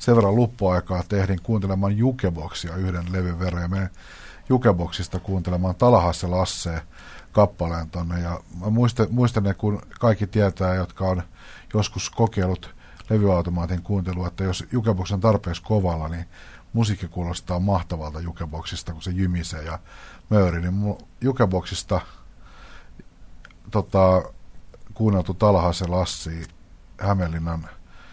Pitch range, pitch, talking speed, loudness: 85-100 Hz, 90 Hz, 115 wpm, -23 LUFS